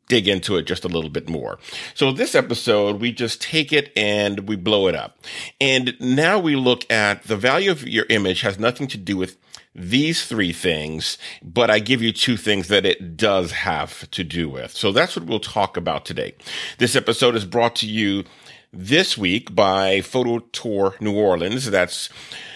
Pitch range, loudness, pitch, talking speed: 100-125 Hz, -20 LUFS, 110 Hz, 190 wpm